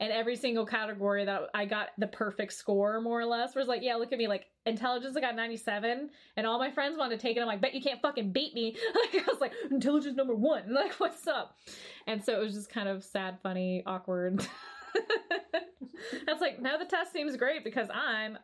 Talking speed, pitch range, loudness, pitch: 225 wpm, 215-285 Hz, -33 LUFS, 235 Hz